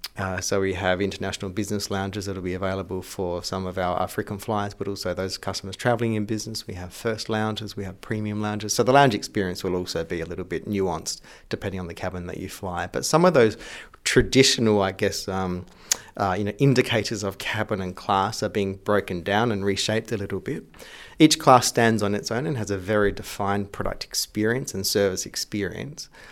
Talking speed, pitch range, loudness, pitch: 205 wpm, 95-110 Hz, -24 LUFS, 100 Hz